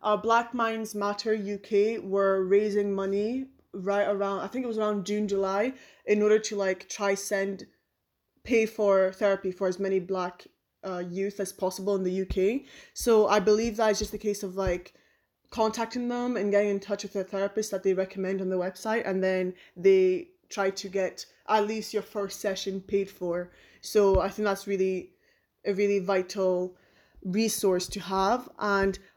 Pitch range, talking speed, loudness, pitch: 190-215 Hz, 180 wpm, -28 LUFS, 200 Hz